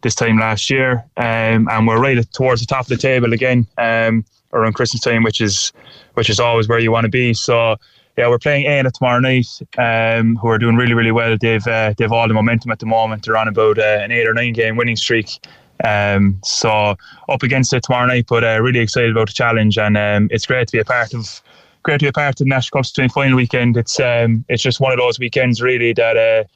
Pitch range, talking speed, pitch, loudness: 110-125 Hz, 245 wpm, 115 Hz, -15 LUFS